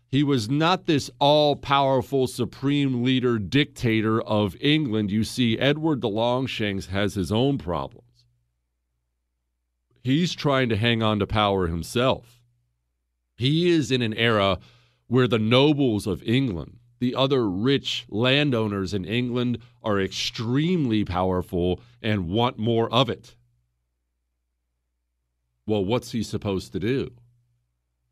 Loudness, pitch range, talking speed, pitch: -23 LUFS, 90-130 Hz, 125 wpm, 115 Hz